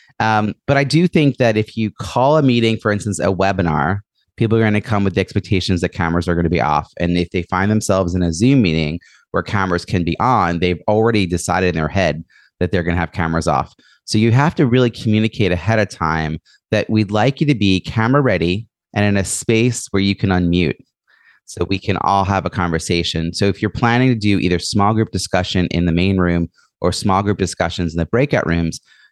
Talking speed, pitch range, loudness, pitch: 230 wpm, 85-110 Hz, -17 LUFS, 95 Hz